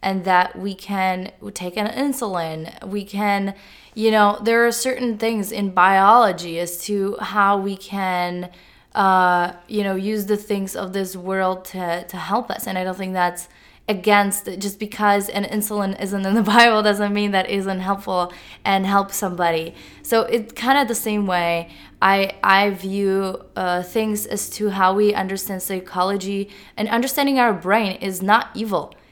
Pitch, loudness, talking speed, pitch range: 200 Hz, -20 LUFS, 170 wpm, 185-210 Hz